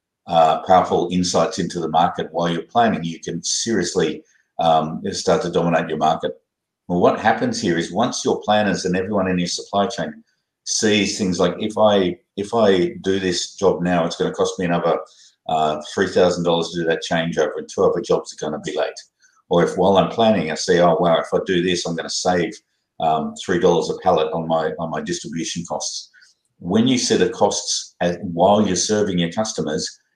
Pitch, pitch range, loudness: 90 Hz, 85-100 Hz, -19 LUFS